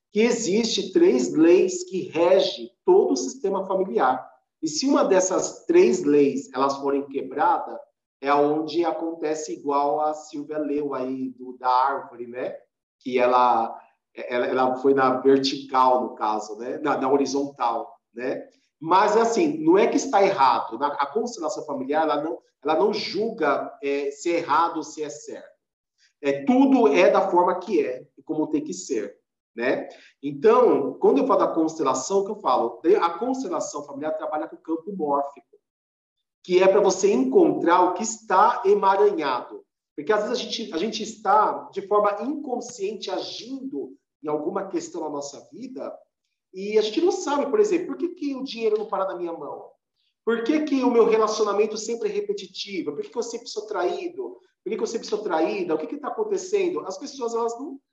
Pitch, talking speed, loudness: 200 Hz, 180 wpm, -23 LUFS